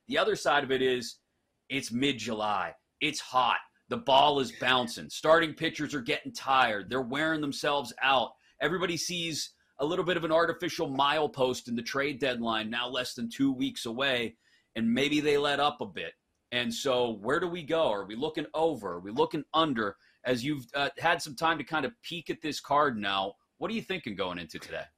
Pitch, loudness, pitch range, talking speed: 145 Hz, -30 LUFS, 125-165 Hz, 205 wpm